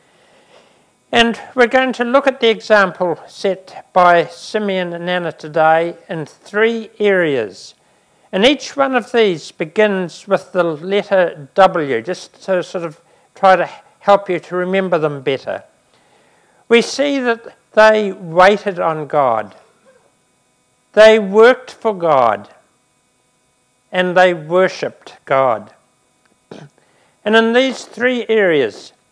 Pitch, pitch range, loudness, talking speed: 190 Hz, 175-225 Hz, -15 LUFS, 120 wpm